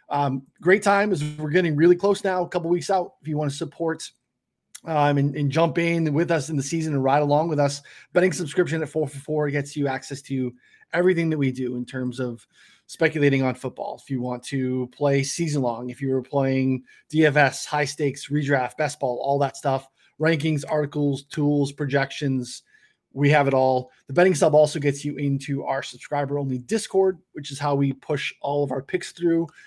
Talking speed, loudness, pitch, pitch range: 205 wpm, -23 LUFS, 145 Hz, 135-160 Hz